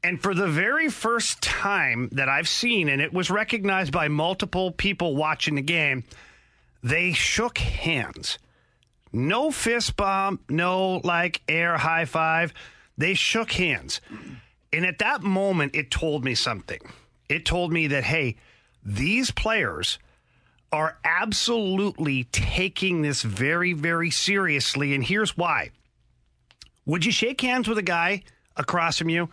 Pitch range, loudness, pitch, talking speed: 145-195 Hz, -24 LUFS, 170 Hz, 140 wpm